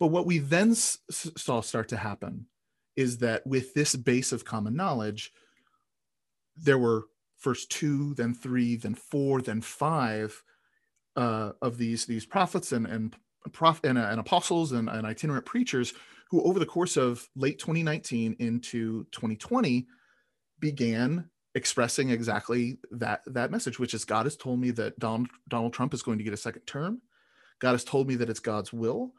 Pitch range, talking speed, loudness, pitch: 115-150 Hz, 160 wpm, -29 LUFS, 125 Hz